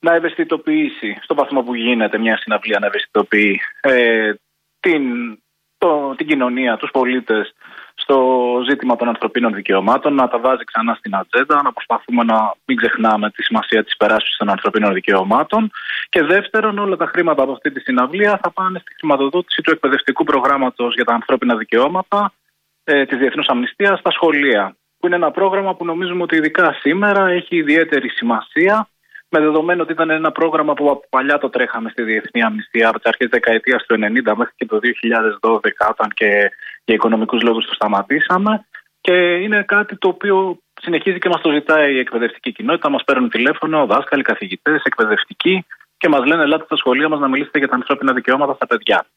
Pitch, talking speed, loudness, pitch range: 155 Hz, 175 wpm, -16 LUFS, 125-185 Hz